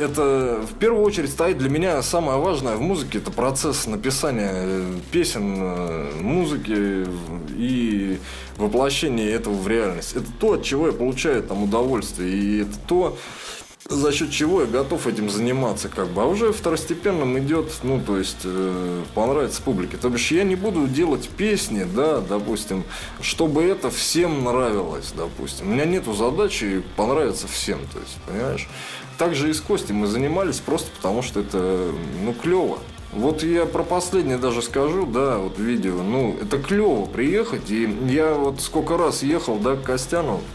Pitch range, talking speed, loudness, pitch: 100-160 Hz, 160 wpm, -22 LUFS, 130 Hz